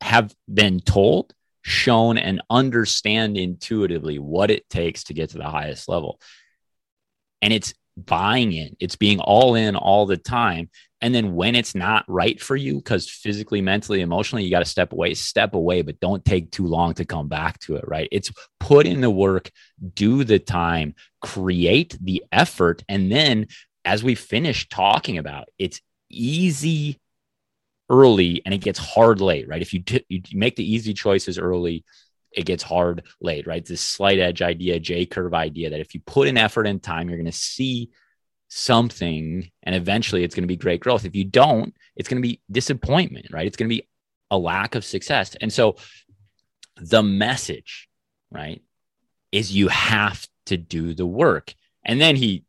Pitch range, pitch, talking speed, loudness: 85-115 Hz, 100 Hz, 180 wpm, -20 LUFS